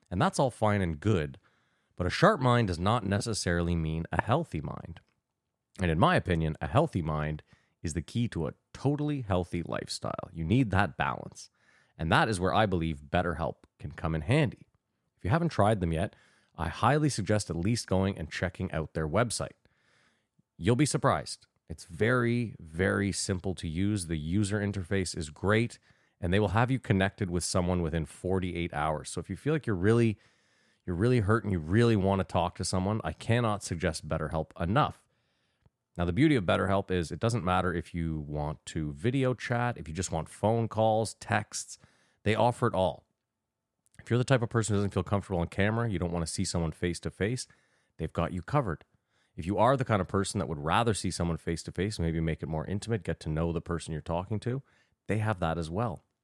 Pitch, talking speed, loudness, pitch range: 95 Hz, 210 wpm, -30 LUFS, 85-110 Hz